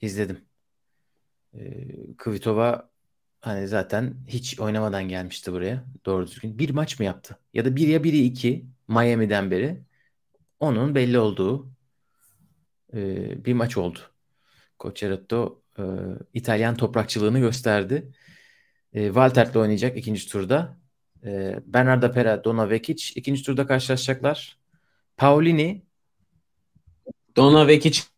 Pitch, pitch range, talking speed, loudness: 120 Hz, 105-135 Hz, 110 wpm, -23 LUFS